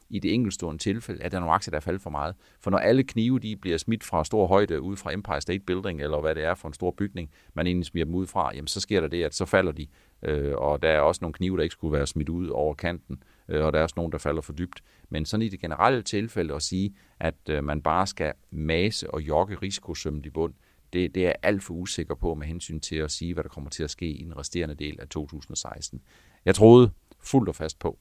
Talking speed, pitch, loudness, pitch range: 265 wpm, 85 Hz, -27 LUFS, 75-95 Hz